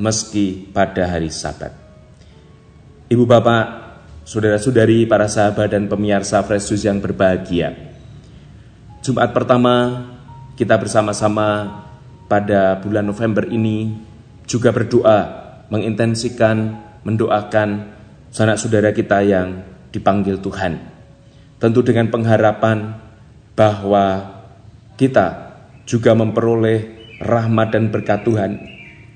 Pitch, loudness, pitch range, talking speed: 110 Hz, -17 LUFS, 100-115 Hz, 90 wpm